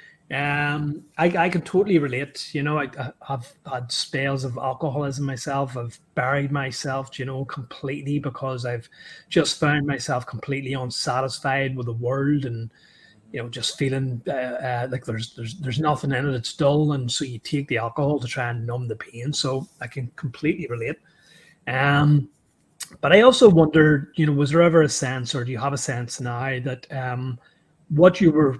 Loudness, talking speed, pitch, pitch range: -23 LUFS, 185 wpm, 135 Hz, 125-150 Hz